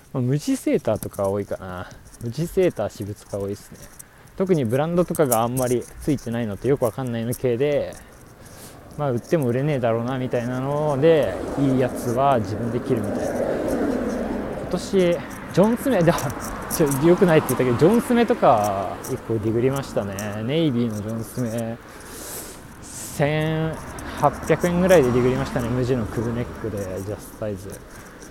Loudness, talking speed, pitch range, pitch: -22 LUFS, 350 characters per minute, 115-155 Hz, 130 Hz